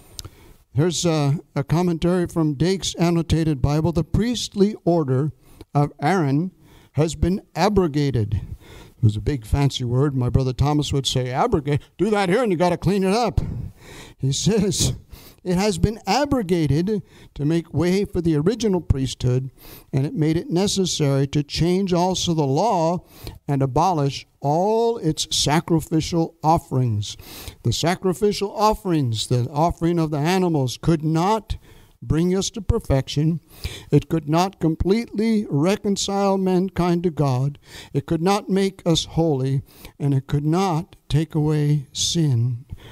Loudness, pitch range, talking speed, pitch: -21 LUFS, 135-180 Hz, 145 wpm, 155 Hz